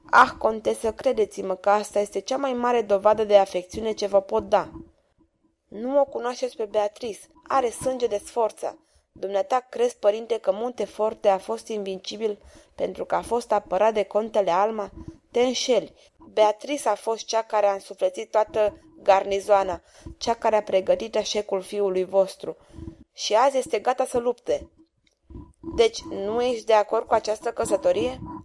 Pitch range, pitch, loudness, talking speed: 205-245 Hz, 215 Hz, -24 LUFS, 155 wpm